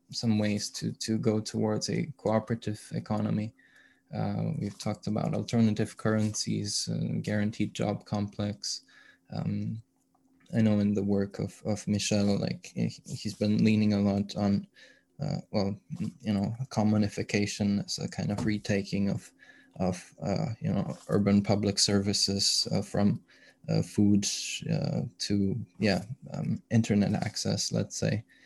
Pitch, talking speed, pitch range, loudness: 105 Hz, 135 wpm, 100-110 Hz, -30 LUFS